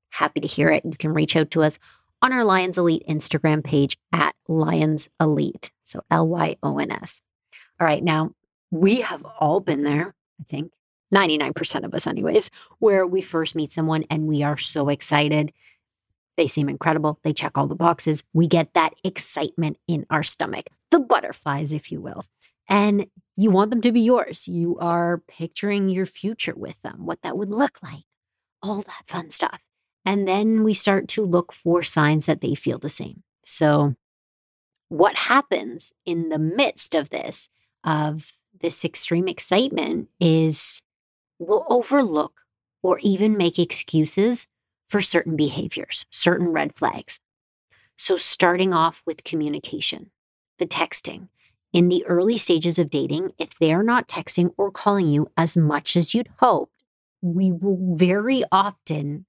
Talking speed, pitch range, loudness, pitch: 160 wpm, 155-195 Hz, -22 LUFS, 170 Hz